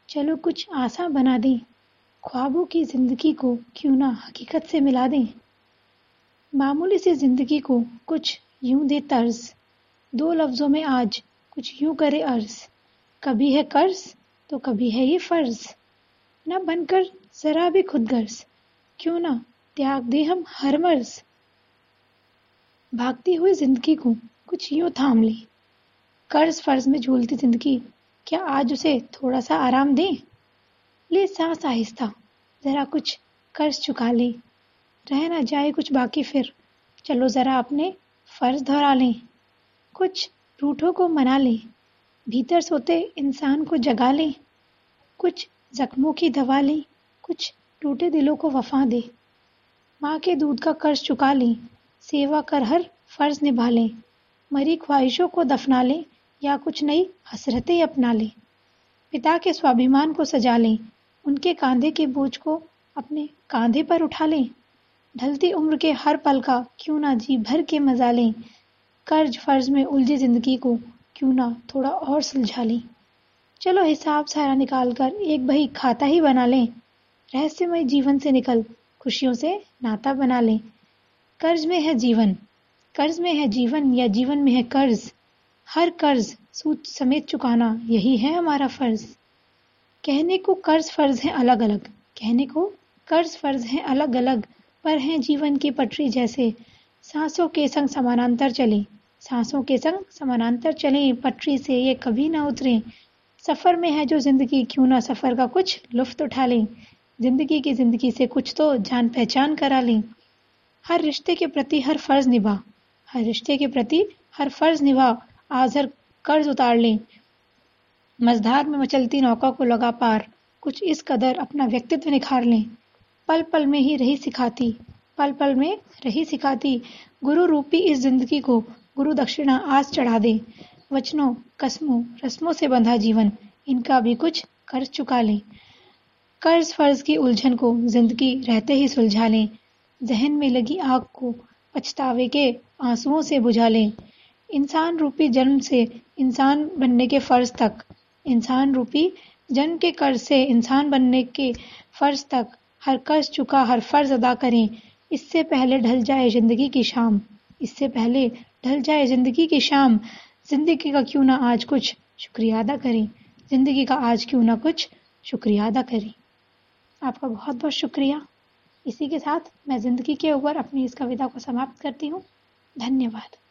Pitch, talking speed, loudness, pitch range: 270 Hz, 155 wpm, -22 LUFS, 245-300 Hz